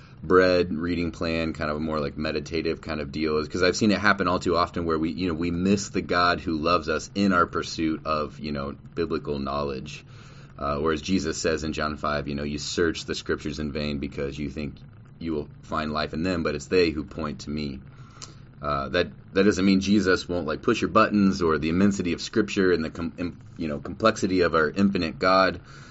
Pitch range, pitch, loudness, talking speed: 75-95 Hz, 80 Hz, -25 LUFS, 225 wpm